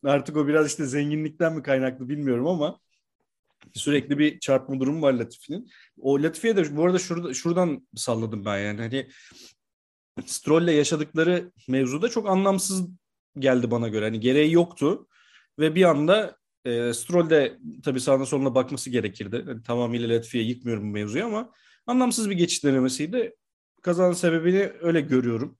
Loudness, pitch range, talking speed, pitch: -24 LUFS, 120-170 Hz, 150 wpm, 145 Hz